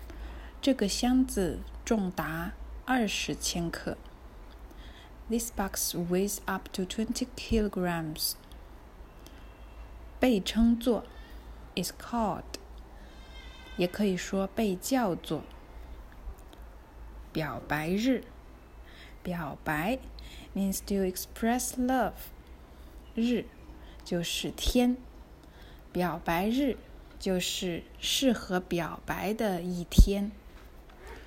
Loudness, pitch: -31 LUFS, 180 Hz